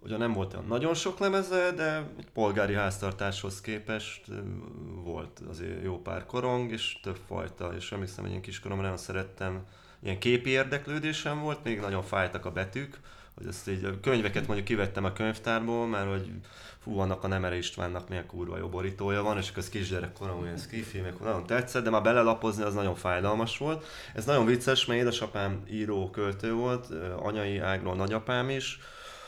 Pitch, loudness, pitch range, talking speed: 100 Hz, -31 LUFS, 95-120 Hz, 170 wpm